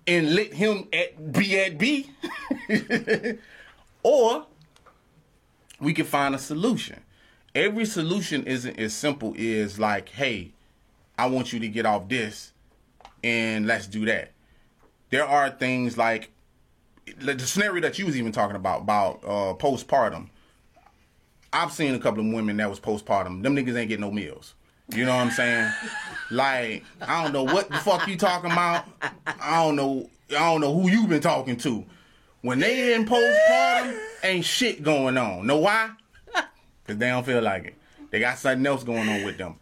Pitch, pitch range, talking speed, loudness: 140 Hz, 115-195 Hz, 175 wpm, -24 LUFS